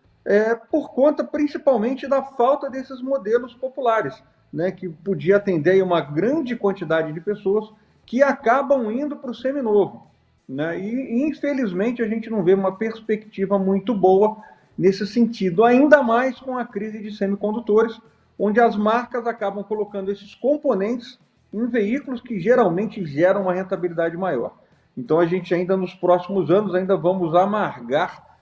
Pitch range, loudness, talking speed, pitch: 190-245 Hz, -21 LUFS, 150 wpm, 215 Hz